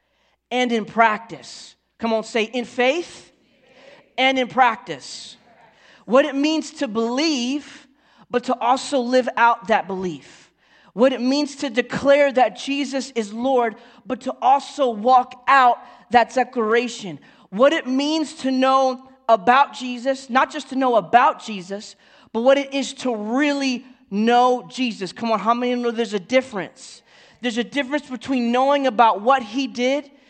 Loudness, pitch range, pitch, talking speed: -20 LUFS, 230-270 Hz, 255 Hz, 155 wpm